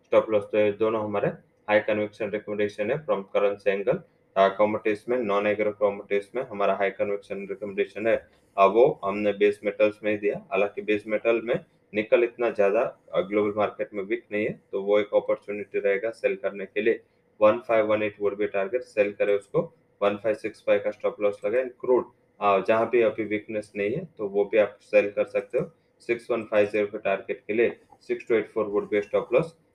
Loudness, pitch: -26 LUFS, 115 Hz